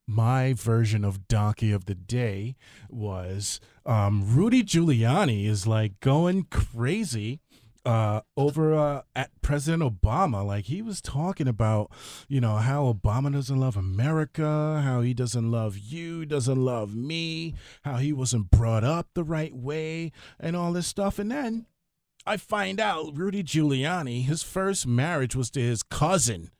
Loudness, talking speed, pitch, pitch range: -26 LUFS, 150 wpm, 130 Hz, 110-160 Hz